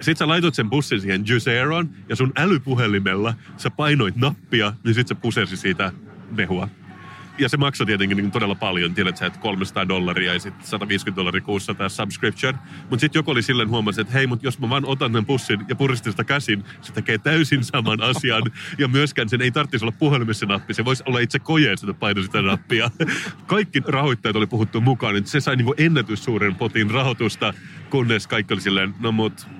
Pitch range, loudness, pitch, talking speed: 105-140 Hz, -21 LUFS, 120 Hz, 195 wpm